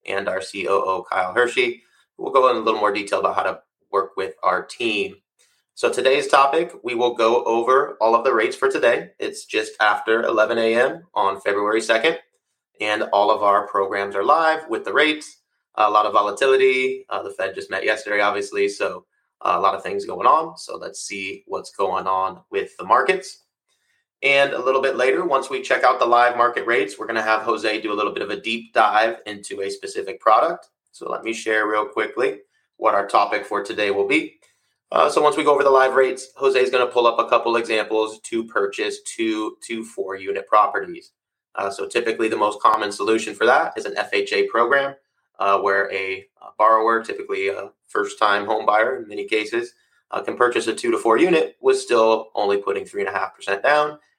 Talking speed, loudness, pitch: 210 wpm, -20 LUFS, 165 Hz